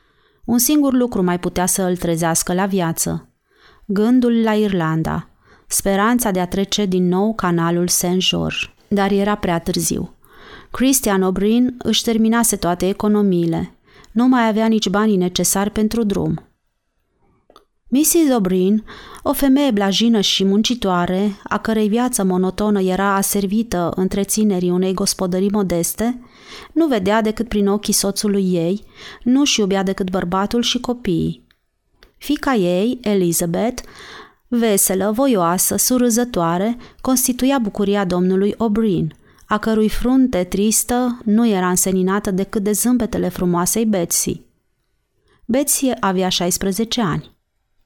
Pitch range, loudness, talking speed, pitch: 185-230 Hz, -17 LUFS, 120 wpm, 205 Hz